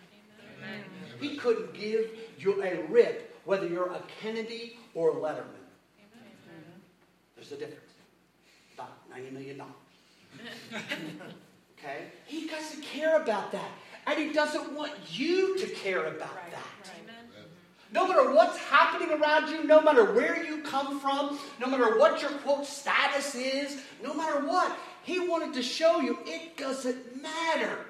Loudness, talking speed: -28 LUFS, 140 wpm